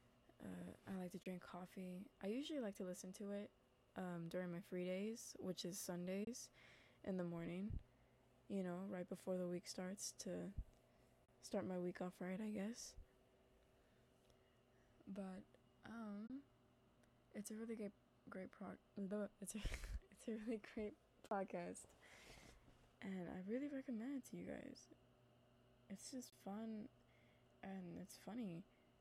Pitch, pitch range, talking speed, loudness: 190 Hz, 175-210 Hz, 145 wpm, -51 LUFS